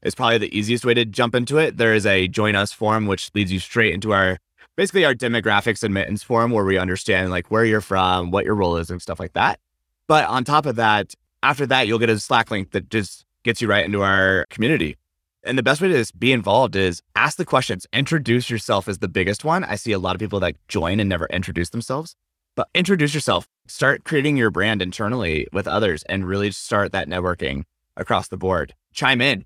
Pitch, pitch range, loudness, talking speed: 105 Hz, 95-120 Hz, -20 LUFS, 225 wpm